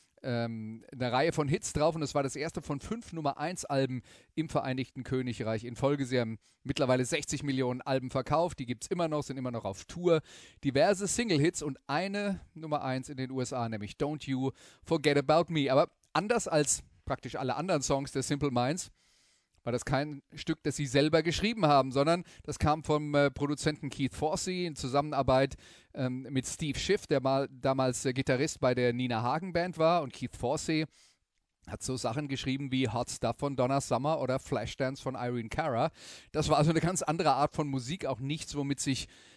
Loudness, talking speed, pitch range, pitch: -31 LUFS, 195 wpm, 130-155 Hz, 140 Hz